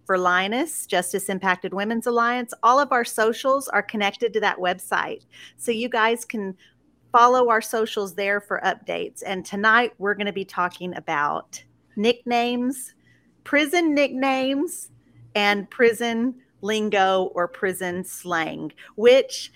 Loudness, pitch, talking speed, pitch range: -22 LUFS, 215 Hz, 130 wpm, 190-240 Hz